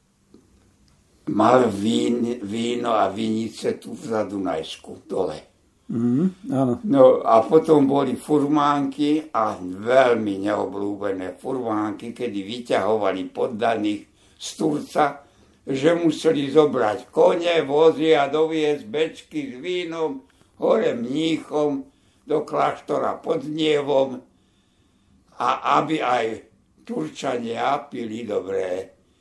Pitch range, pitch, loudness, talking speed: 110-155 Hz, 135 Hz, -22 LUFS, 90 wpm